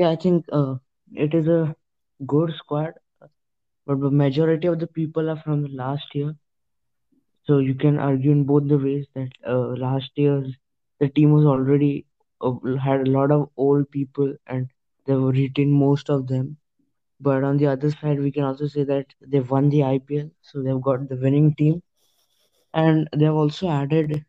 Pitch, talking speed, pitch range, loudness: 145 Hz, 180 wpm, 135-150 Hz, -22 LUFS